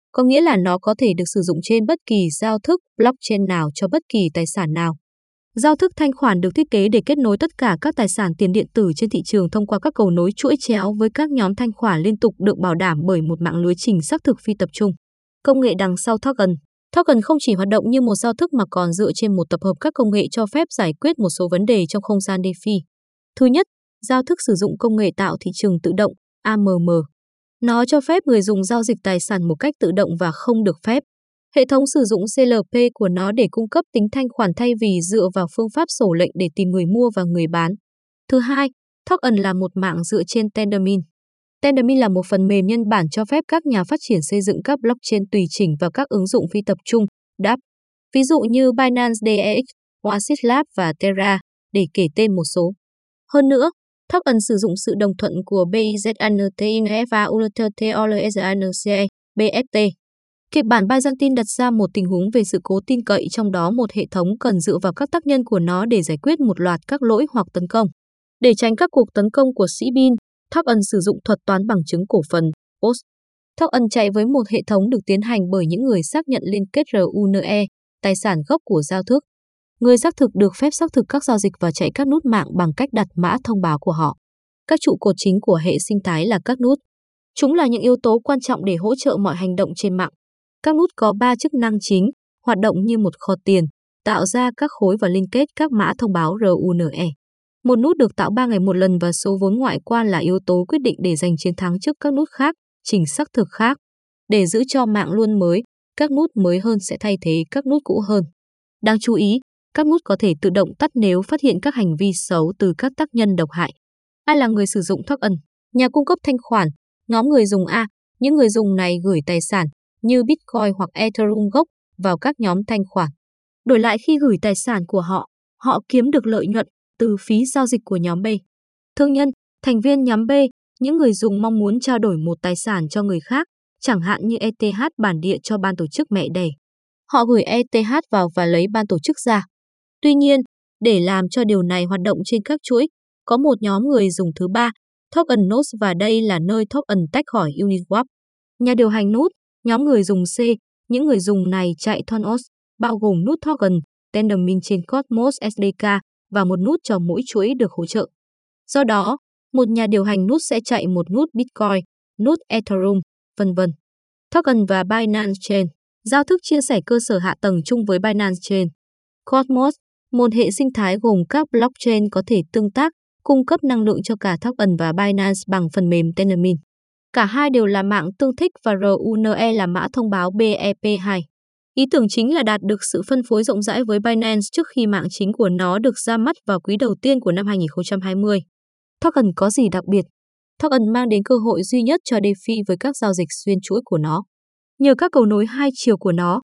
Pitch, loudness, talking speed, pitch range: 215 Hz, -18 LUFS, 225 wpm, 190-250 Hz